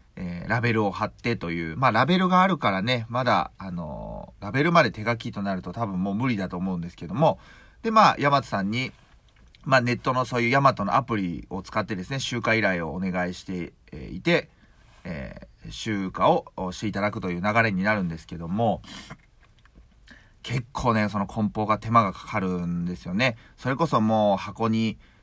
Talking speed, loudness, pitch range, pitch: 365 characters per minute, -25 LUFS, 95-120 Hz, 110 Hz